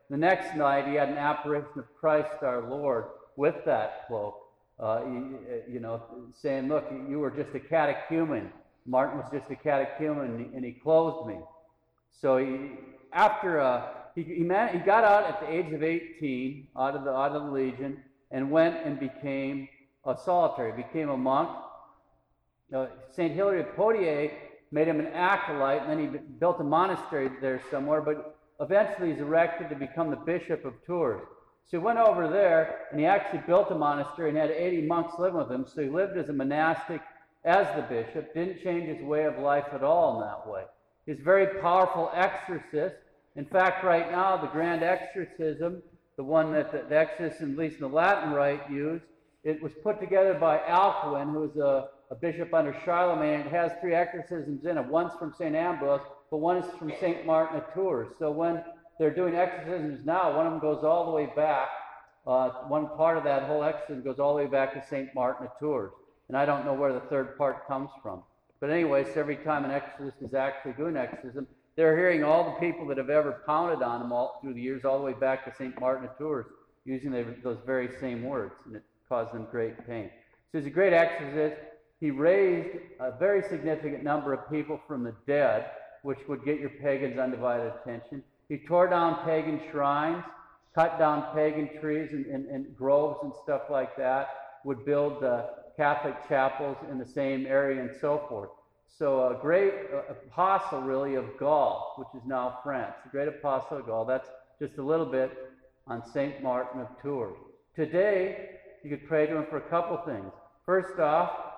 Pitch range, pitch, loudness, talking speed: 135-165 Hz, 150 Hz, -29 LUFS, 195 wpm